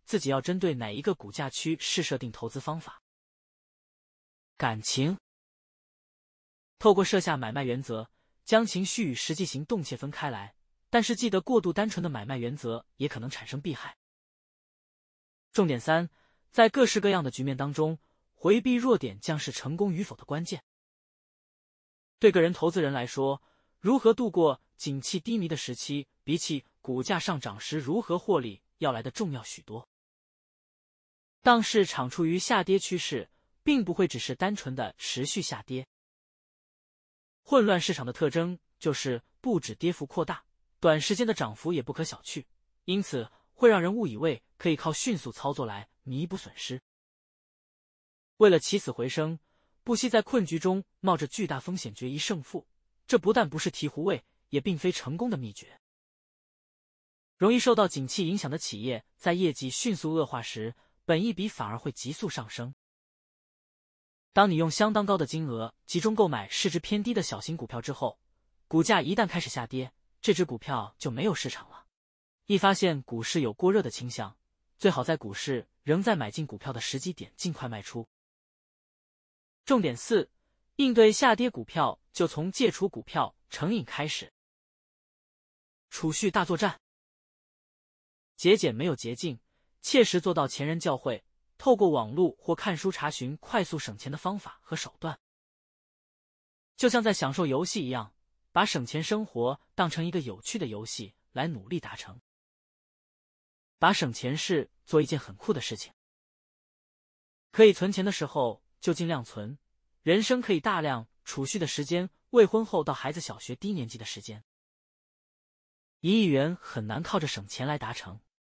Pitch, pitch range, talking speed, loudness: 160 Hz, 130-195 Hz, 240 characters per minute, -29 LUFS